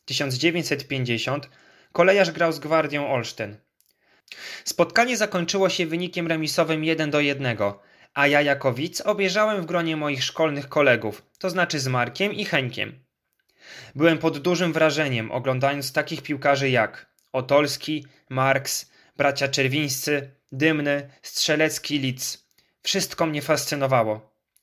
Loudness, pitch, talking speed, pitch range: -23 LUFS, 145 Hz, 115 wpm, 135-165 Hz